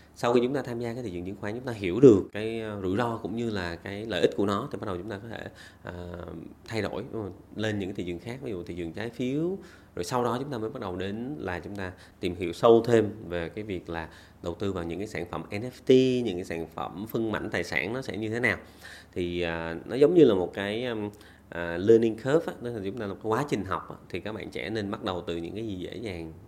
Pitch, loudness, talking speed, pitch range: 105 Hz, -28 LUFS, 285 wpm, 85-115 Hz